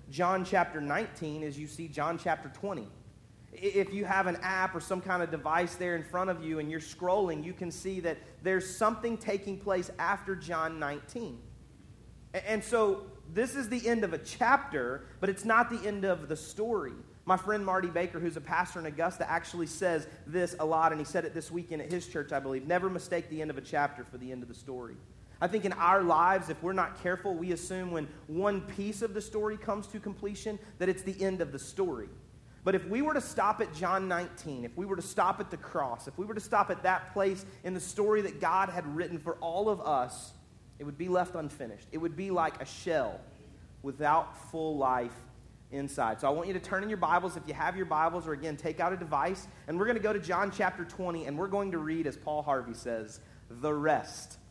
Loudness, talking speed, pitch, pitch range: -33 LUFS, 230 wpm, 175 Hz, 150-195 Hz